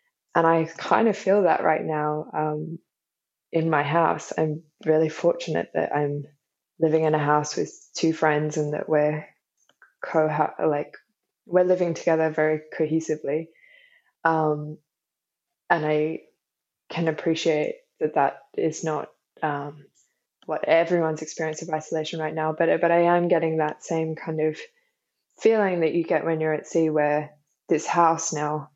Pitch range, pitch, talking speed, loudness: 155-170 Hz, 160 Hz, 150 wpm, -24 LUFS